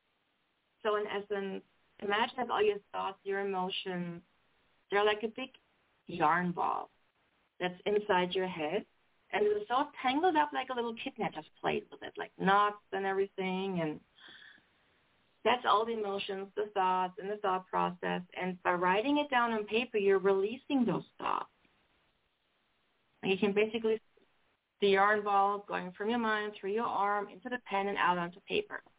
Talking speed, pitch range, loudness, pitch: 170 wpm, 190-230 Hz, -33 LUFS, 200 Hz